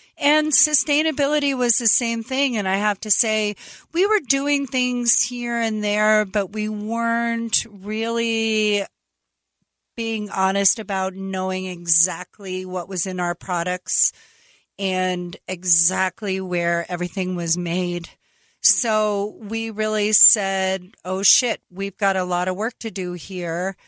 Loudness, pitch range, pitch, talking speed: -19 LUFS, 185-230 Hz, 205 Hz, 135 wpm